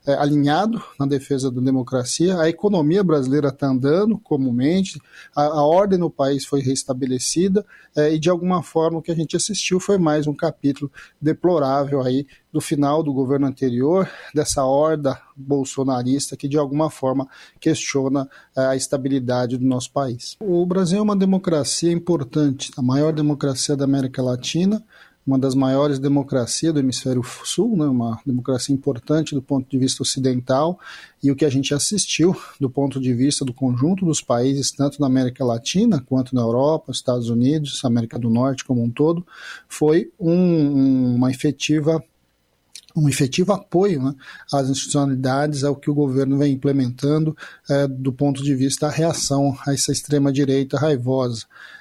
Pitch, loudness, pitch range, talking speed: 140 Hz, -20 LUFS, 130-155 Hz, 160 wpm